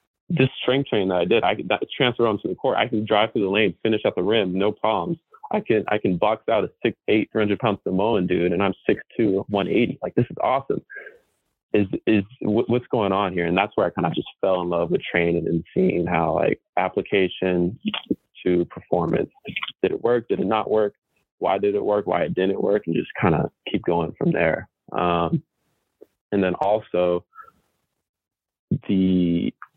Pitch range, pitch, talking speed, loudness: 90-120 Hz, 100 Hz, 200 wpm, -22 LUFS